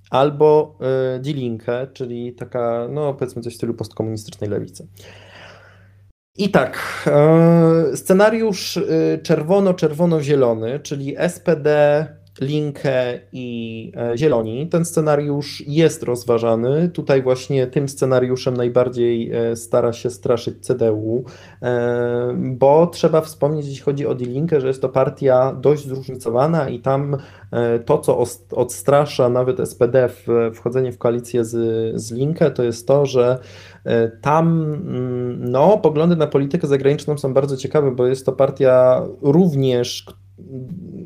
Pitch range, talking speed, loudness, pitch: 120-150 Hz, 120 wpm, -18 LUFS, 130 Hz